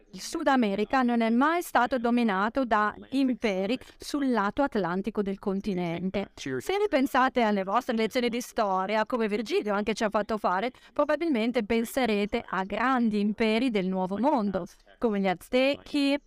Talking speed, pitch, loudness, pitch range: 150 wpm, 230 Hz, -27 LUFS, 205-260 Hz